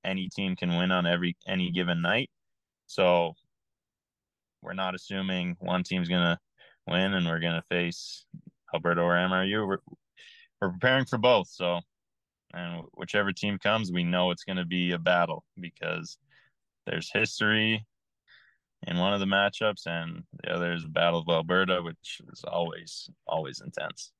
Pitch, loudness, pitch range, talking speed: 90 Hz, -28 LUFS, 85-100 Hz, 155 wpm